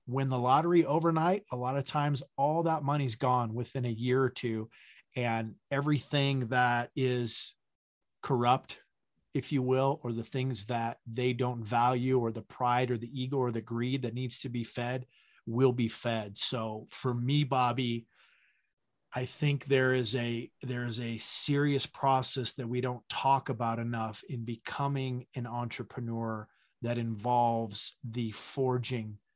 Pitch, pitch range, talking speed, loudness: 125 Hz, 115-135 Hz, 155 wpm, -31 LUFS